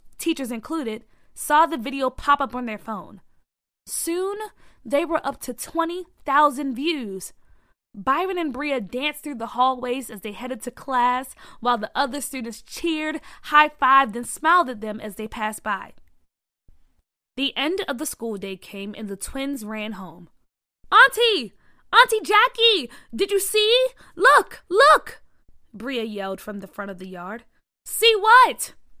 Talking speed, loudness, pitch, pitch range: 155 wpm, -21 LUFS, 260 Hz, 215-320 Hz